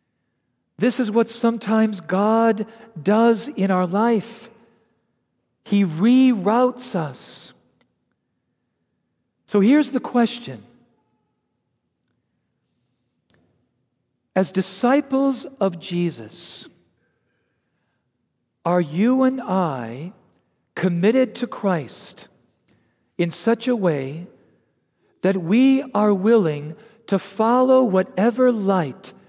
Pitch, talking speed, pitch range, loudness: 205 Hz, 80 wpm, 170-230 Hz, -20 LUFS